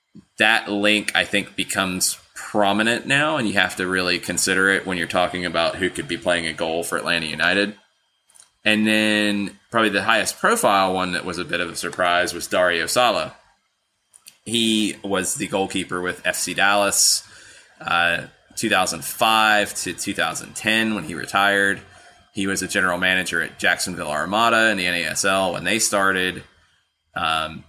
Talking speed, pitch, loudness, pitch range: 160 wpm, 95 Hz, -20 LUFS, 90-105 Hz